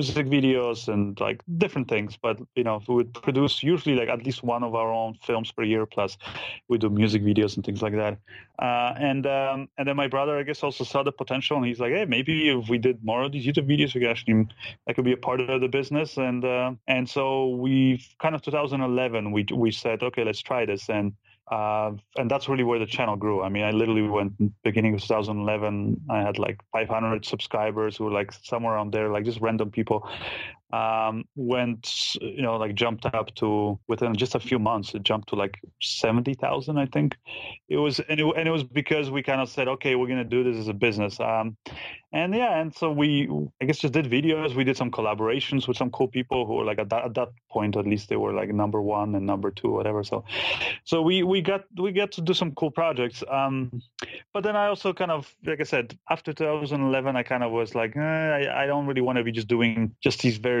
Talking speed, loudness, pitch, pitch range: 235 wpm, -26 LUFS, 125 Hz, 110-140 Hz